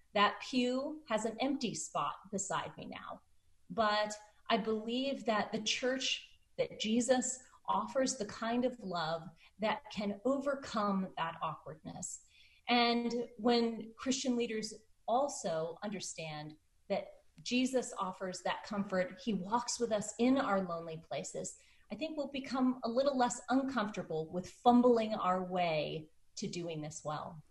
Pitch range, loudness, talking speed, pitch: 190-250 Hz, -36 LUFS, 135 wpm, 220 Hz